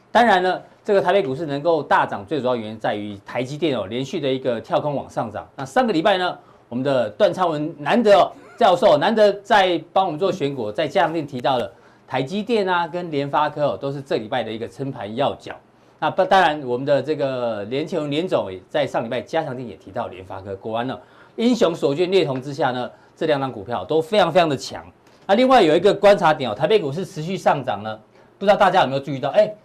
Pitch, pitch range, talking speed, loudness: 150 Hz, 125-185 Hz, 345 characters per minute, -20 LUFS